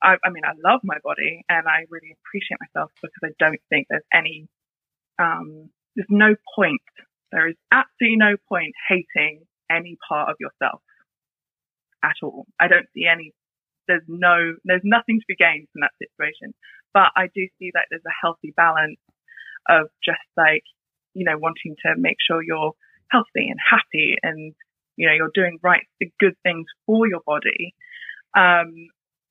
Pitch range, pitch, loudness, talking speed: 160-195 Hz, 170 Hz, -19 LUFS, 170 wpm